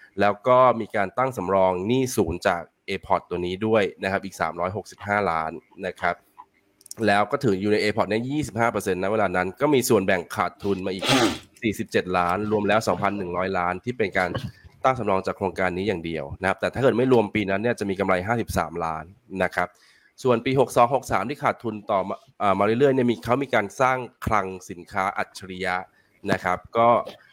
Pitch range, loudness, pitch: 95-115 Hz, -24 LUFS, 100 Hz